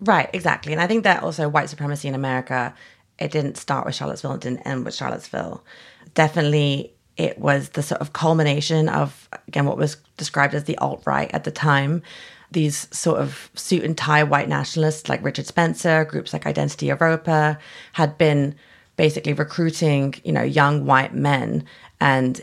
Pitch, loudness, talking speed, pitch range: 150 Hz, -21 LUFS, 170 wpm, 140-160 Hz